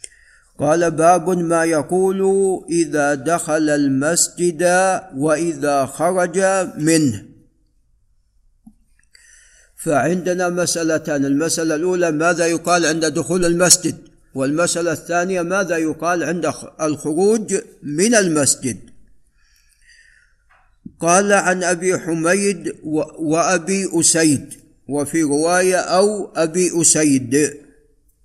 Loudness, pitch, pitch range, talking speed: -17 LUFS, 165 Hz, 155-180 Hz, 80 wpm